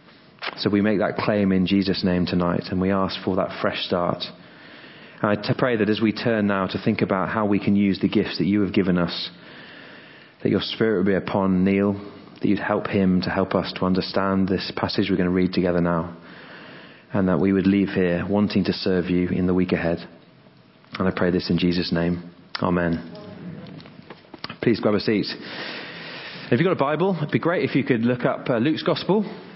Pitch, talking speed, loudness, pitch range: 95 Hz, 210 wpm, -22 LUFS, 90-105 Hz